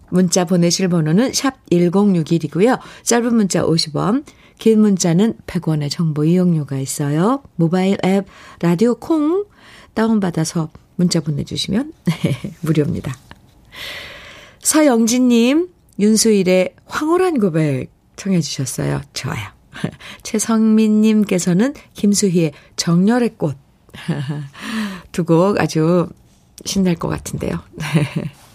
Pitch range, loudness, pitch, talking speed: 165-220 Hz, -17 LUFS, 185 Hz, 220 characters per minute